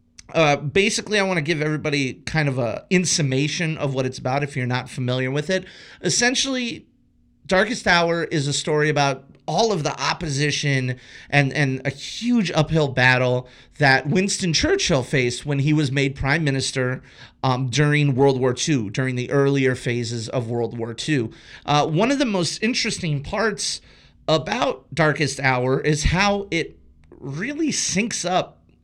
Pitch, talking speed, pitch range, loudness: 145 Hz, 160 wpm, 130-175 Hz, -21 LUFS